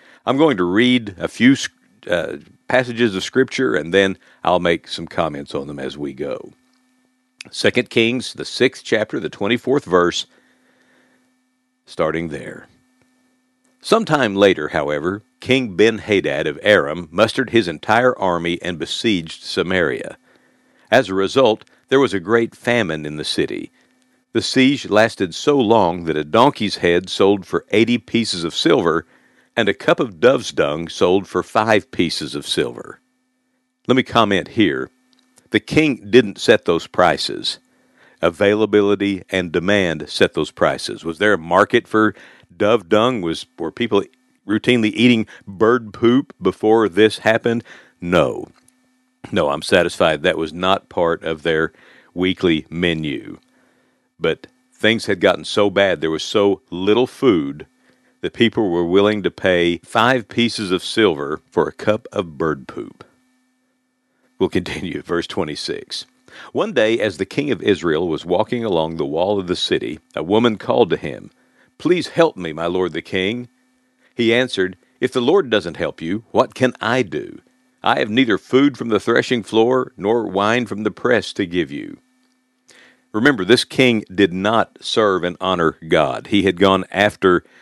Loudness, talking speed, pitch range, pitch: -18 LUFS, 155 wpm, 95-125 Hz, 110 Hz